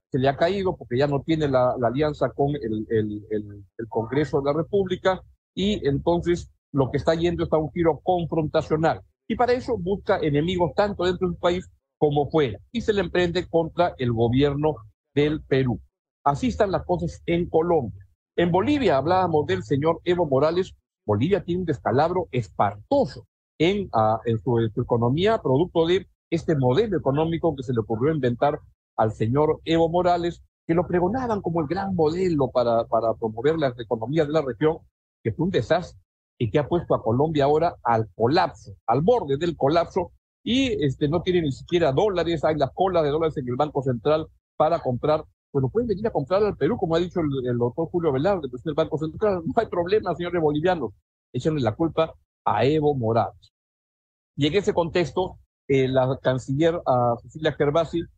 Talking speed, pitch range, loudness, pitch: 185 wpm, 130-175 Hz, -24 LUFS, 155 Hz